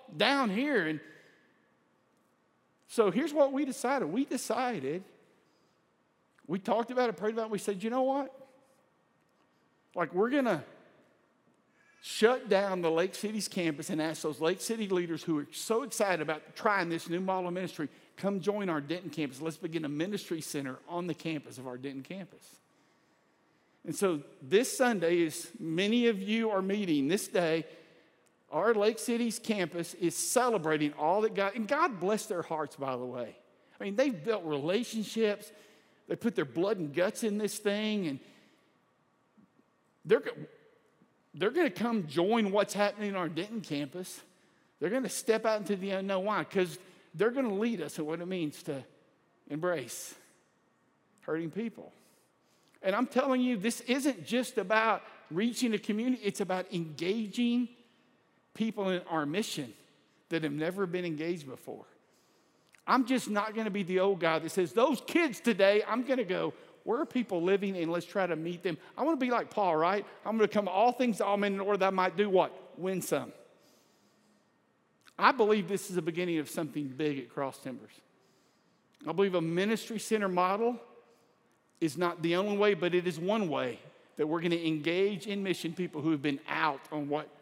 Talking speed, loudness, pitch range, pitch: 185 wpm, -32 LUFS, 165-225 Hz, 195 Hz